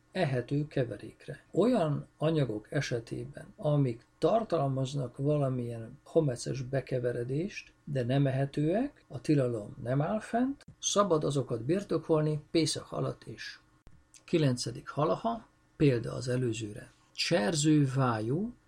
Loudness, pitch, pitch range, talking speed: -31 LUFS, 145 Hz, 125-160 Hz, 95 wpm